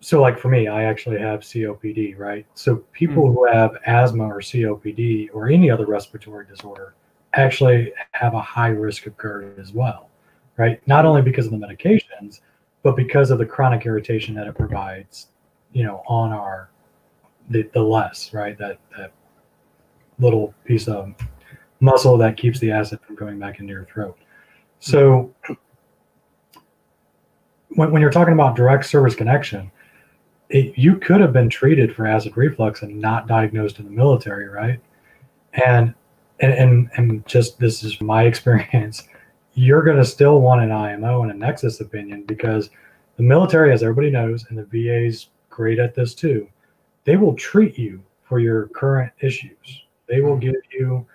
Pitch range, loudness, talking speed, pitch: 105-130 Hz, -18 LUFS, 165 wpm, 115 Hz